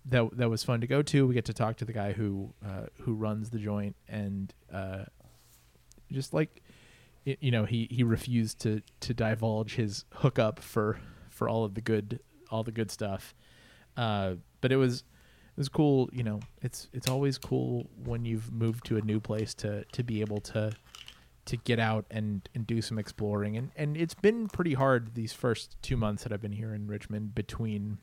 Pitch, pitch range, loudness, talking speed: 115 Hz, 105-125 Hz, -32 LUFS, 205 wpm